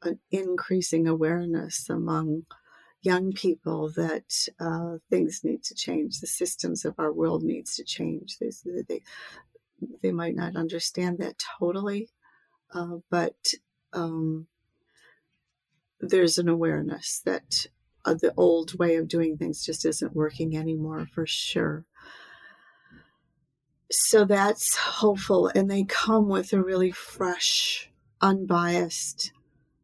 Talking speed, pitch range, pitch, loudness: 120 wpm, 165-185 Hz, 170 Hz, -26 LUFS